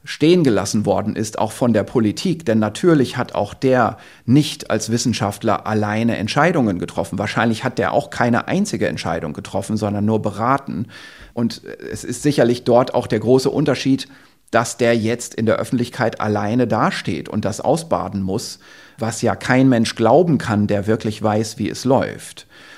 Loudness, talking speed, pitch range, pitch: -18 LUFS, 165 wpm, 105-125 Hz, 115 Hz